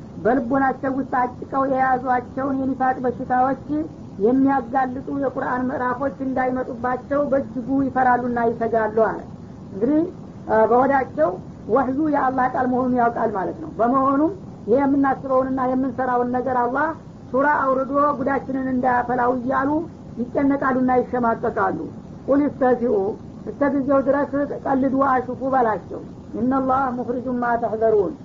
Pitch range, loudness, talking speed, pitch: 245-270 Hz, -21 LUFS, 100 wpm, 260 Hz